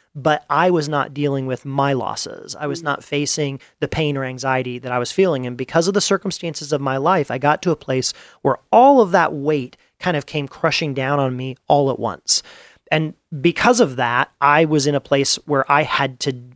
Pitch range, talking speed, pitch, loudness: 135-165 Hz, 220 wpm, 145 Hz, -19 LUFS